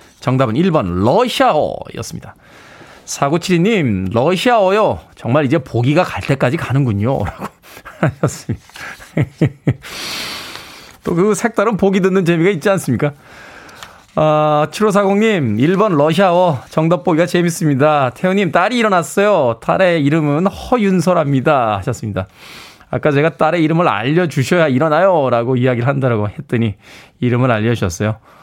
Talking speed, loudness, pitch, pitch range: 300 characters per minute, -15 LUFS, 155 Hz, 130-185 Hz